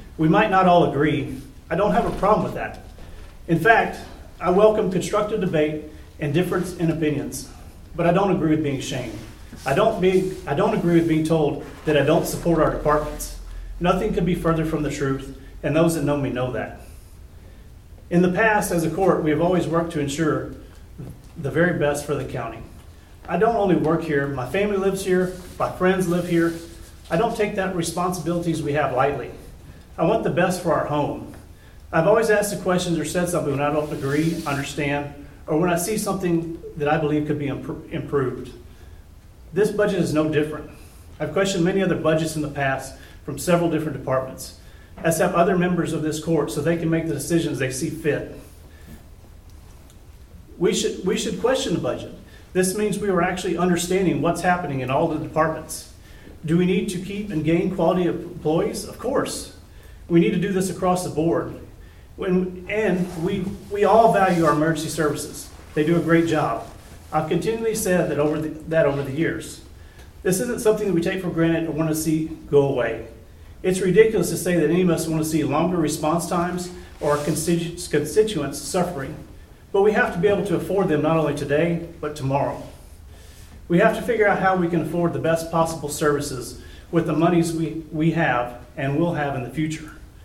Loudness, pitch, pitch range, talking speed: -22 LUFS, 160 Hz, 145-180 Hz, 195 wpm